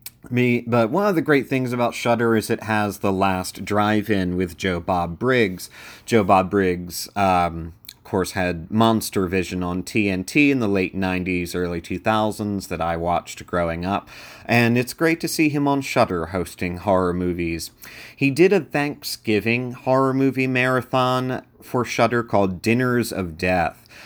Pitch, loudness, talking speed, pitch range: 105 Hz, -21 LUFS, 165 wpm, 90-125 Hz